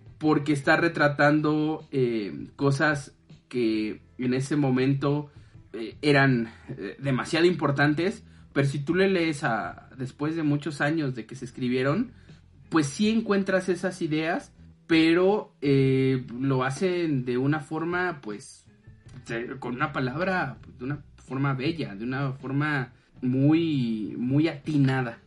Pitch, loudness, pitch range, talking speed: 140 Hz, -26 LUFS, 125-155 Hz, 130 wpm